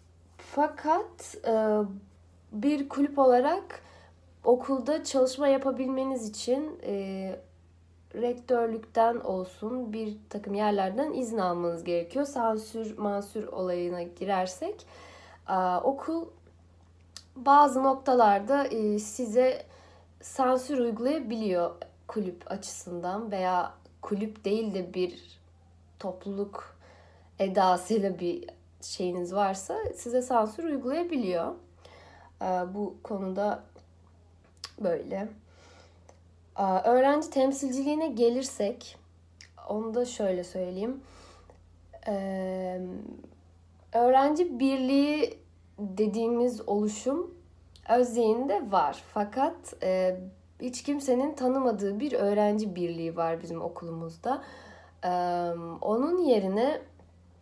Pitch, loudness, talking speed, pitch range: 205 Hz, -29 LUFS, 70 wpm, 170-255 Hz